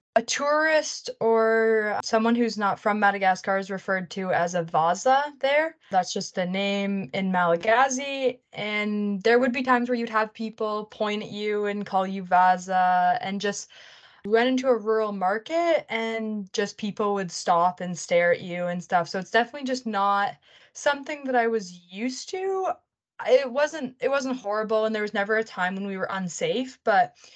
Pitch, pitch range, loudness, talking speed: 210 Hz, 190-250 Hz, -25 LUFS, 180 wpm